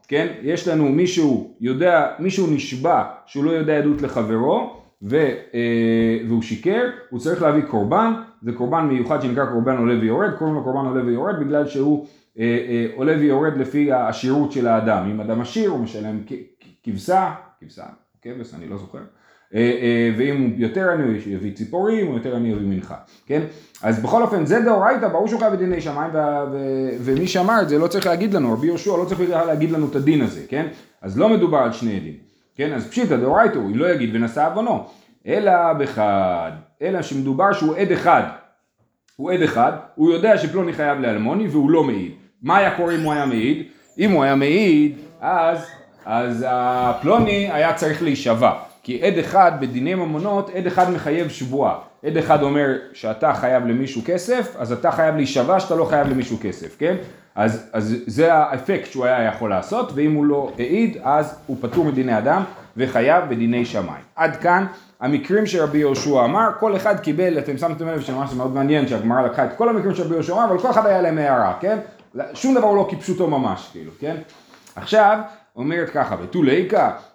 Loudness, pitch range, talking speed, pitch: -19 LUFS, 125-180 Hz, 180 wpm, 150 Hz